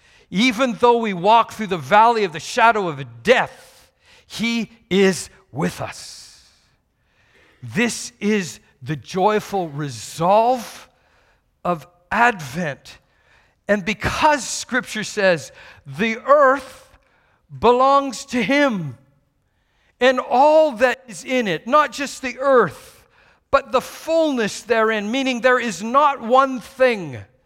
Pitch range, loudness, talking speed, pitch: 185-260 Hz, -19 LUFS, 115 wpm, 230 Hz